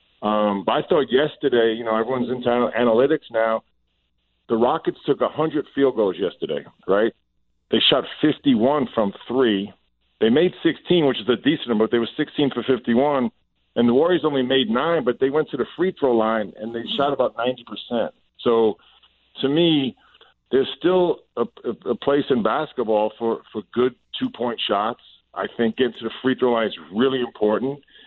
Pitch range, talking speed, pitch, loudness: 110-140 Hz, 180 wpm, 120 Hz, -21 LUFS